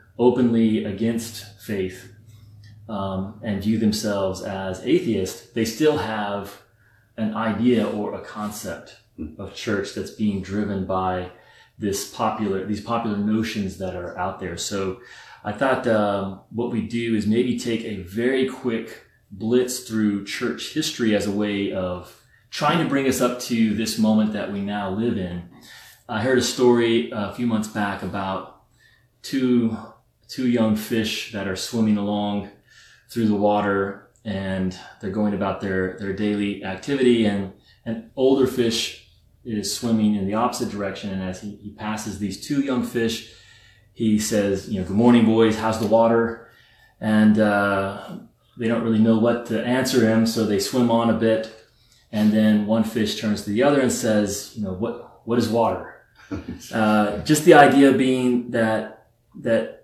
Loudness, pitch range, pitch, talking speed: -22 LUFS, 100-115 Hz, 110 Hz, 160 wpm